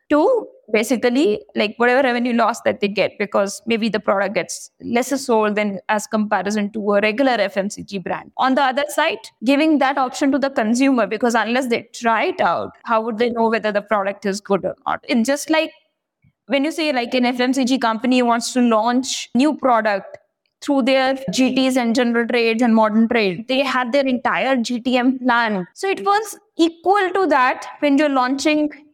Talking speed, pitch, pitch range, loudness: 185 wpm, 245 Hz, 220-280 Hz, -18 LUFS